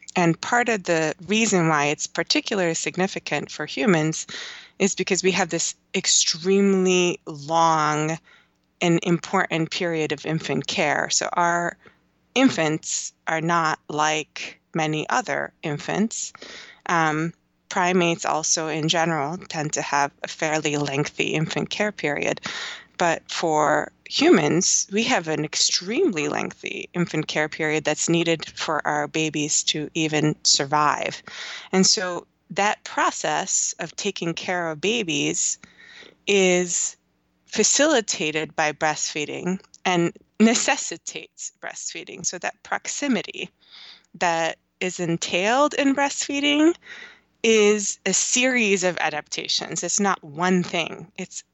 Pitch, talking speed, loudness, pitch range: 170 Hz, 115 wpm, -22 LUFS, 155-200 Hz